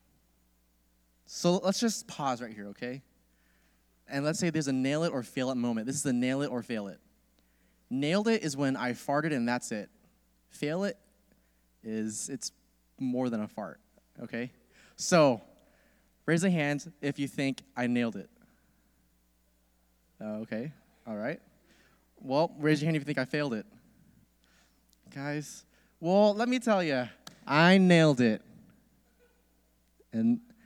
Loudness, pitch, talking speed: -30 LUFS, 125 Hz, 150 wpm